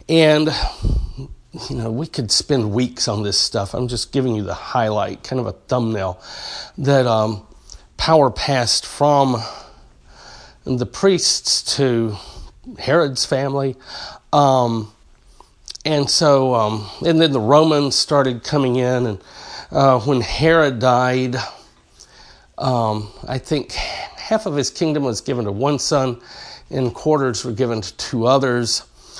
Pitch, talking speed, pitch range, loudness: 130 Hz, 135 wpm, 115-140 Hz, -18 LUFS